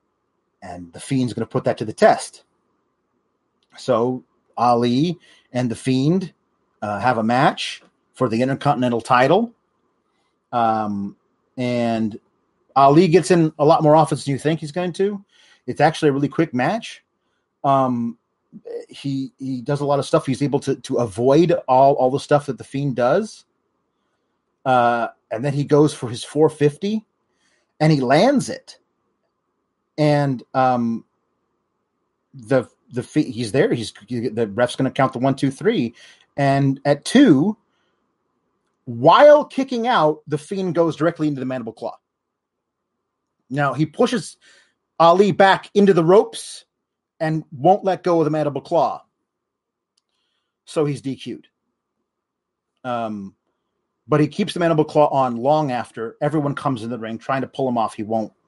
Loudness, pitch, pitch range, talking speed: -19 LUFS, 140 Hz, 125-160 Hz, 155 wpm